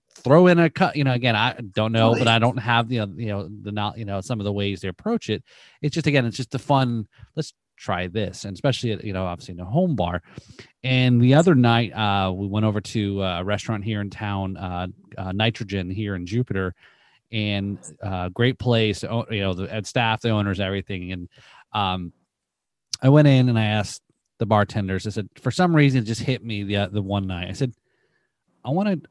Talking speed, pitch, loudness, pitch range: 220 wpm, 110 Hz, -22 LUFS, 100-125 Hz